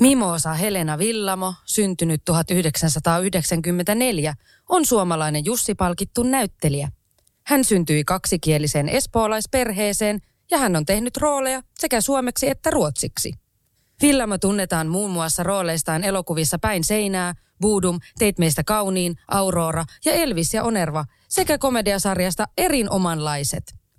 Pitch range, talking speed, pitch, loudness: 165-225 Hz, 105 wpm, 190 Hz, -21 LUFS